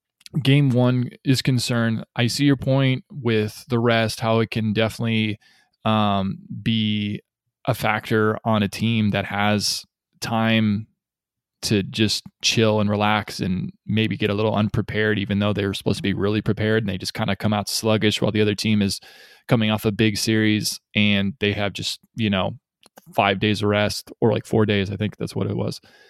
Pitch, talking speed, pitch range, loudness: 110 Hz, 190 wpm, 105-115 Hz, -22 LUFS